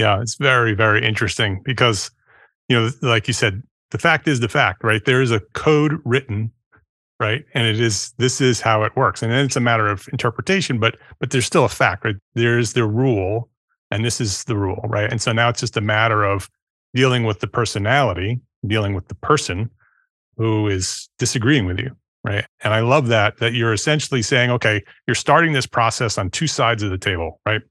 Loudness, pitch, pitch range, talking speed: -19 LUFS, 115 Hz, 110-130 Hz, 210 wpm